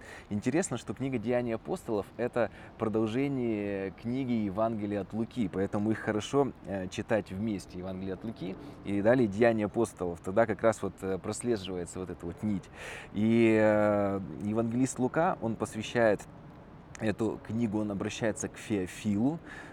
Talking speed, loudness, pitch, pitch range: 130 wpm, -31 LUFS, 110 Hz, 100-115 Hz